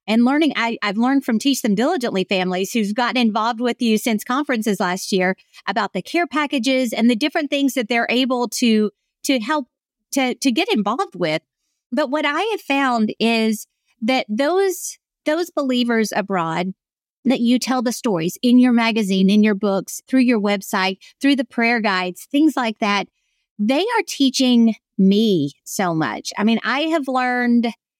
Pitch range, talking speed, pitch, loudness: 210-270 Hz, 175 wpm, 240 Hz, -19 LUFS